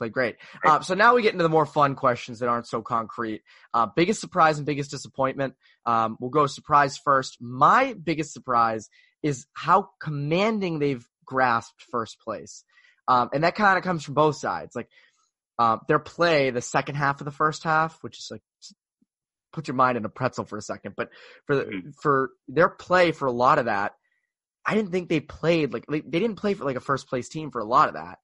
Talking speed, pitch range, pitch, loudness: 215 wpm, 125-165 Hz, 145 Hz, -24 LUFS